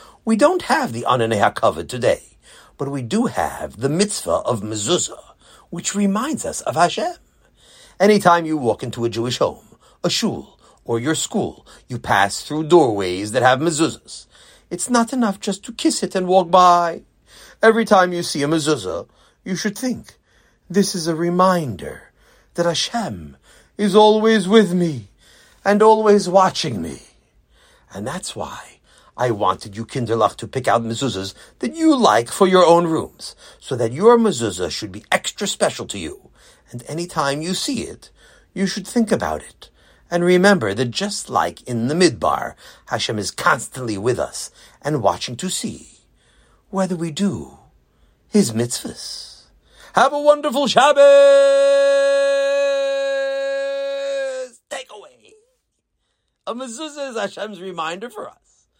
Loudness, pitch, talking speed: -18 LUFS, 190 Hz, 150 wpm